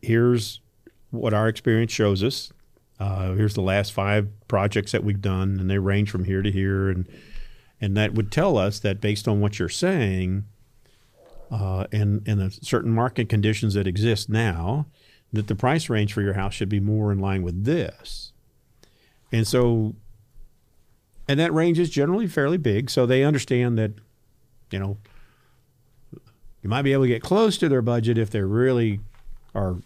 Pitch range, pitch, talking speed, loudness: 100-125 Hz, 110 Hz, 175 wpm, -23 LUFS